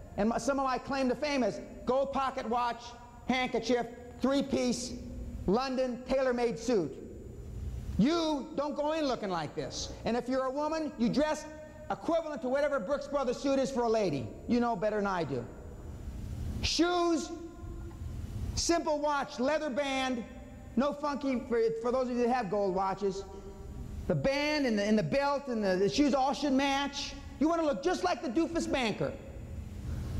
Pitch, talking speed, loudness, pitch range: 260 Hz, 175 wpm, -32 LUFS, 230-290 Hz